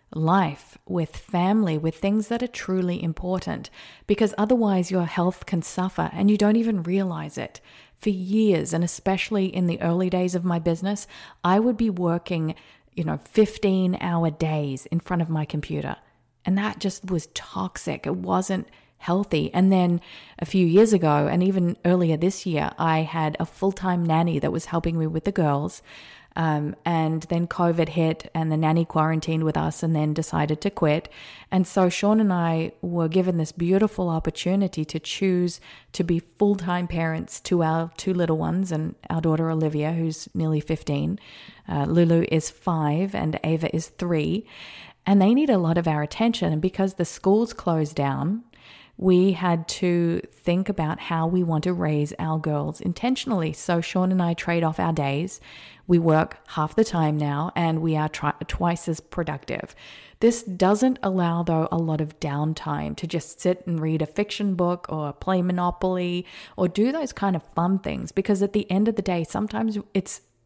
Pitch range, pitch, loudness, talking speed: 160-190 Hz, 175 Hz, -24 LUFS, 180 wpm